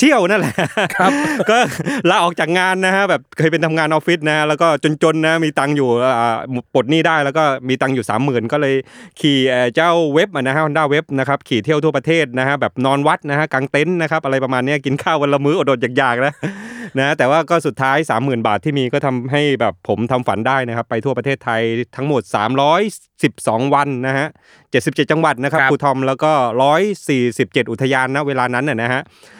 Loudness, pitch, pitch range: -16 LUFS, 140 Hz, 130-155 Hz